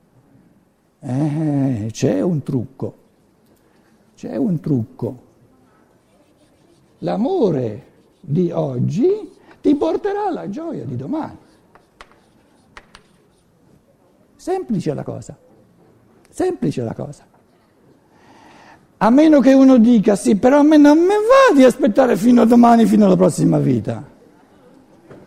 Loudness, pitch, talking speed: -15 LUFS, 230 Hz, 100 wpm